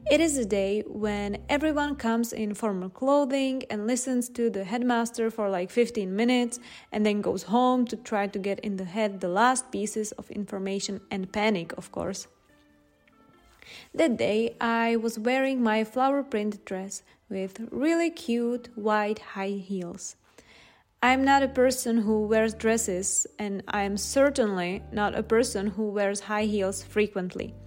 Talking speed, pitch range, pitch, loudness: 160 wpm, 200-245 Hz, 215 Hz, -27 LUFS